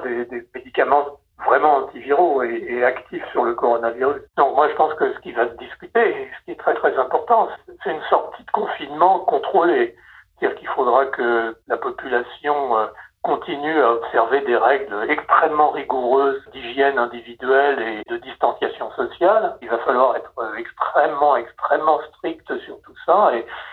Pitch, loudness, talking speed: 145 Hz, -20 LUFS, 160 wpm